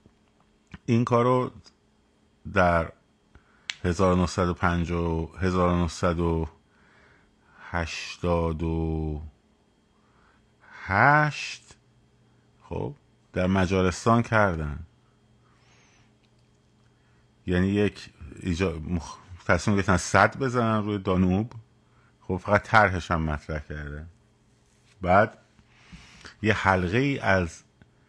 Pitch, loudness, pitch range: 95 Hz, -25 LUFS, 85-110 Hz